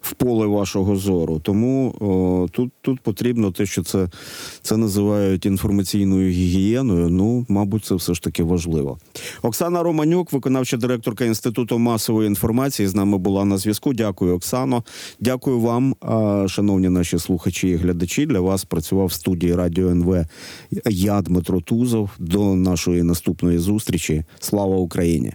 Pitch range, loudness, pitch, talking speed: 90-115 Hz, -20 LUFS, 100 Hz, 140 wpm